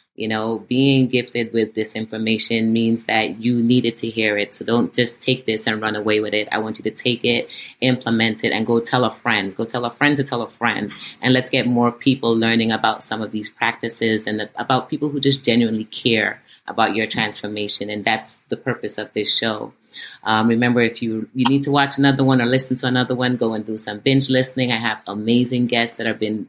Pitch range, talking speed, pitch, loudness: 110-125 Hz, 230 wpm, 115 Hz, -19 LUFS